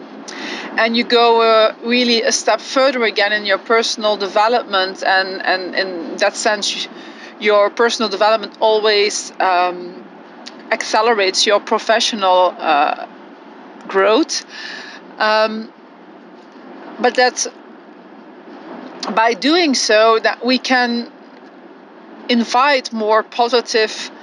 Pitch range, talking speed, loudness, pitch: 215-300 Hz, 100 wpm, -15 LUFS, 235 Hz